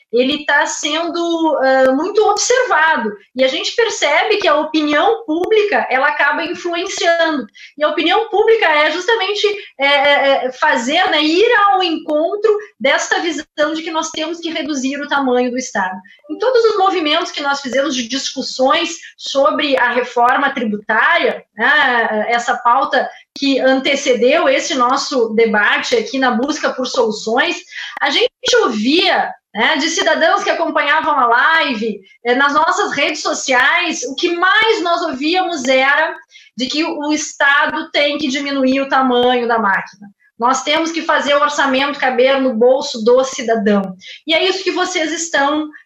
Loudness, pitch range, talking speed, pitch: -14 LUFS, 260-335 Hz, 155 wpm, 295 Hz